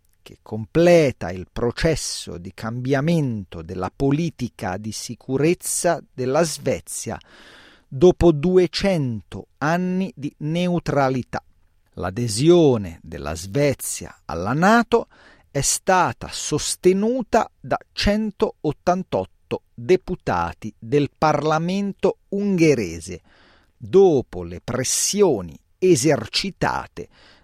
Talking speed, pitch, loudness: 75 wpm, 140 Hz, -21 LUFS